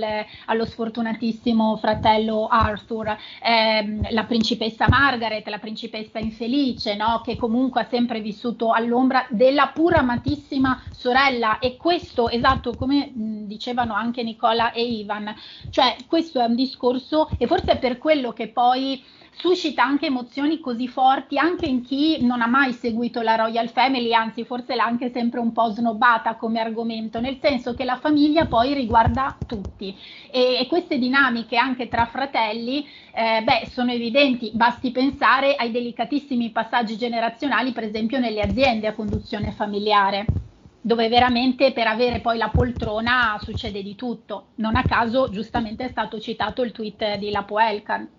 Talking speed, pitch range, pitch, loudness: 155 wpm, 225-260 Hz, 240 Hz, -21 LUFS